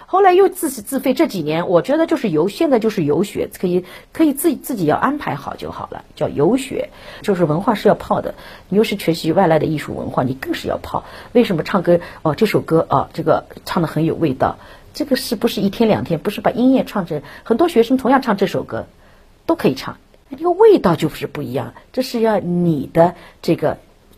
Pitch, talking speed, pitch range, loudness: 210 Hz, 320 characters per minute, 165-265 Hz, -17 LUFS